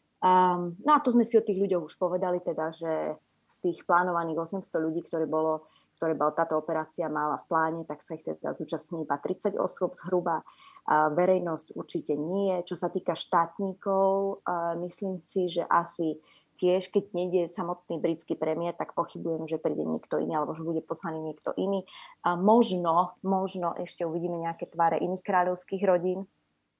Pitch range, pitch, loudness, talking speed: 160-185 Hz, 175 Hz, -29 LUFS, 165 wpm